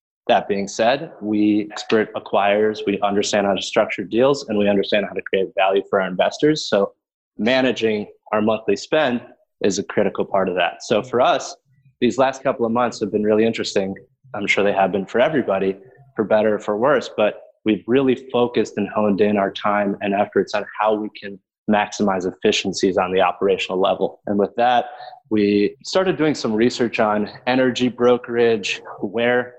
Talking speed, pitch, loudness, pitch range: 185 wpm, 110 Hz, -20 LUFS, 105-125 Hz